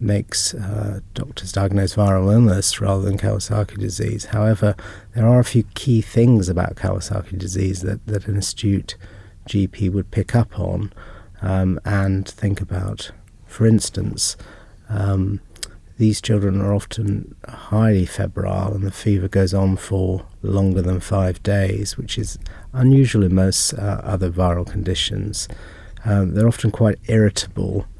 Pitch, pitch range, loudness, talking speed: 100 Hz, 95-105 Hz, -20 LUFS, 140 wpm